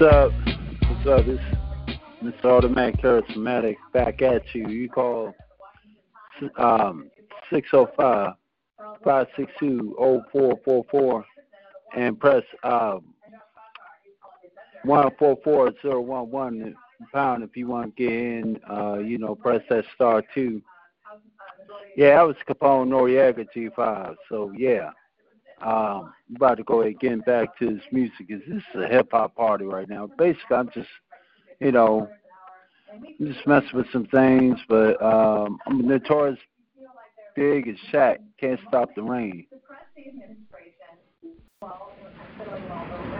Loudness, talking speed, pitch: -22 LUFS, 135 wpm, 135 Hz